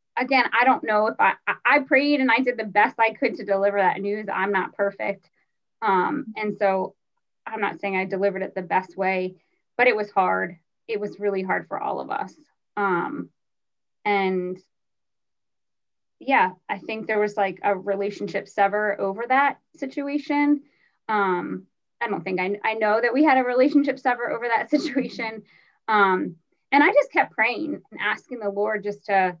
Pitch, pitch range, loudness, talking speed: 210 Hz, 195-255 Hz, -23 LUFS, 180 wpm